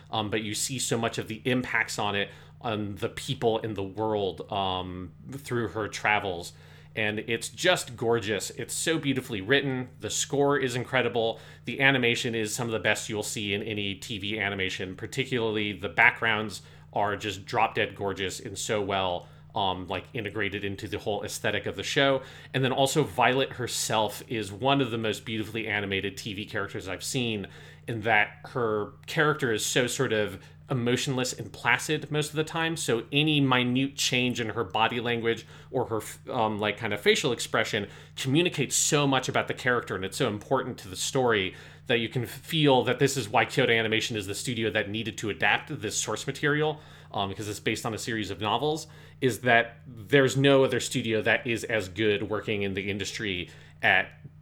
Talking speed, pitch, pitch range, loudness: 190 wpm, 115 Hz, 105-130 Hz, -27 LUFS